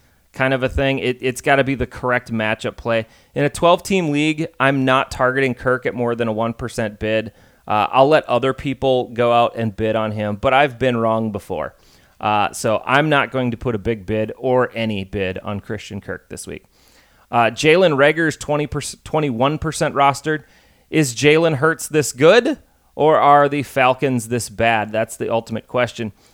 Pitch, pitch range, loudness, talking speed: 125 Hz, 110-140 Hz, -18 LUFS, 190 wpm